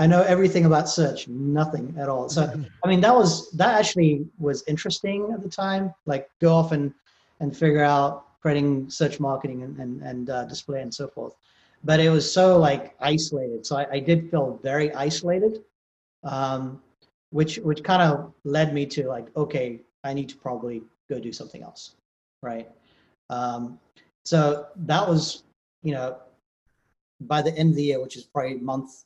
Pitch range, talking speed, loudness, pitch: 135-160 Hz, 180 wpm, -23 LUFS, 145 Hz